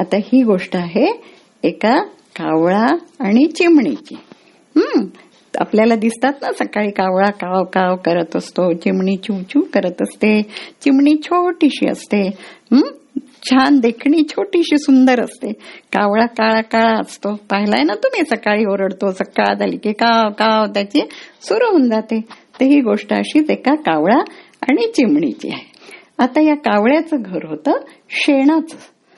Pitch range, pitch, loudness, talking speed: 205-300 Hz, 240 Hz, -15 LUFS, 135 wpm